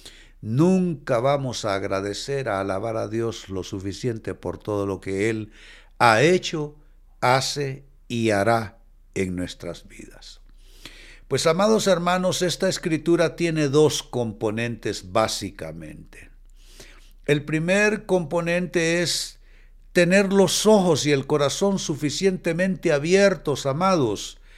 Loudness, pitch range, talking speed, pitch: -22 LUFS, 110-175 Hz, 110 wpm, 145 Hz